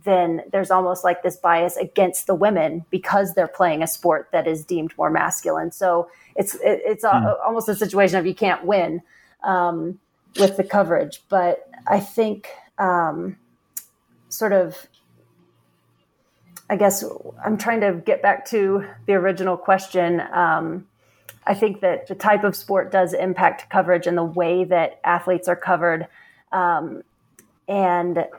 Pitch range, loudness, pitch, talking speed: 175-200 Hz, -20 LUFS, 185 Hz, 150 wpm